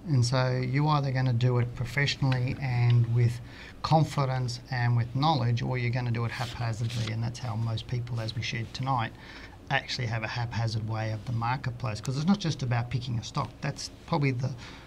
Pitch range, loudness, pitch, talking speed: 115-130 Hz, -29 LUFS, 125 Hz, 200 wpm